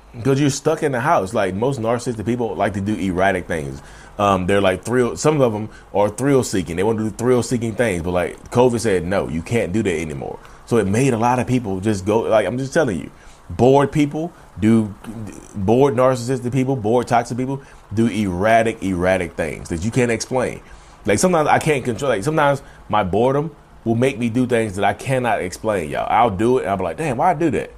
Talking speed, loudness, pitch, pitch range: 225 wpm, -19 LUFS, 120 Hz, 105-135 Hz